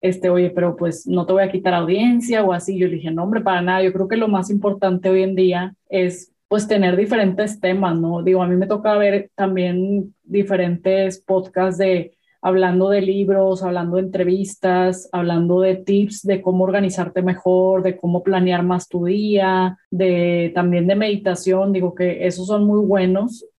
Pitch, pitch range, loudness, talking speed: 185 Hz, 180-195 Hz, -18 LUFS, 185 wpm